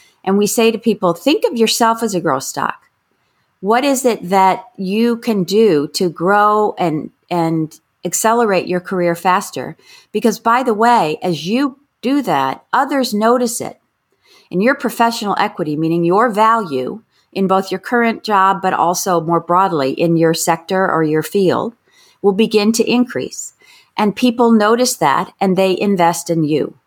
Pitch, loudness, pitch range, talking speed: 200 Hz, -15 LUFS, 175-230 Hz, 165 wpm